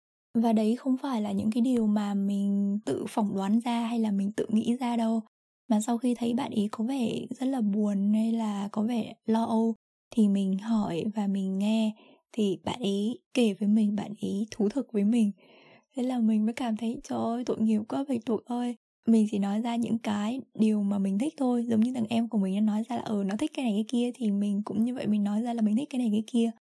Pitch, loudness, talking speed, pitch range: 220 Hz, -28 LUFS, 255 wpm, 210-235 Hz